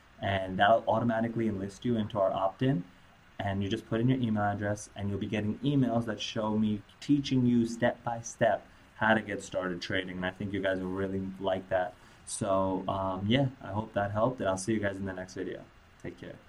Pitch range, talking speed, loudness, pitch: 95-115 Hz, 230 wpm, -31 LUFS, 100 Hz